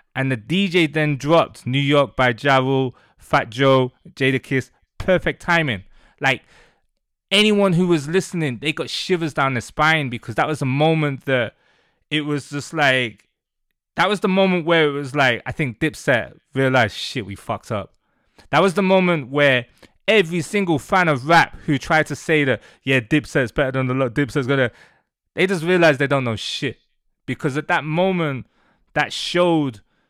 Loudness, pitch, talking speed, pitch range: -19 LUFS, 145 Hz, 175 wpm, 130-170 Hz